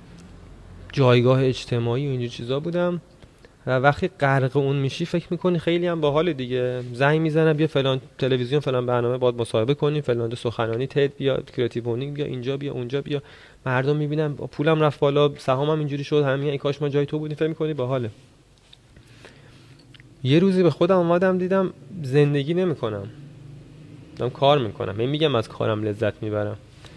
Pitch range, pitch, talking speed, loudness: 125-150 Hz, 140 Hz, 160 wpm, -23 LUFS